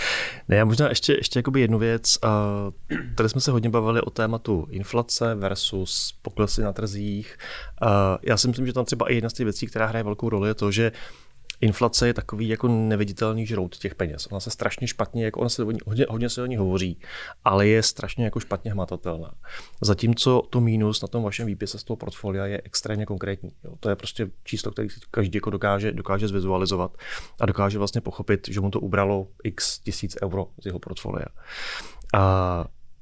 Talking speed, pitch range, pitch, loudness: 190 wpm, 100-115 Hz, 110 Hz, -25 LUFS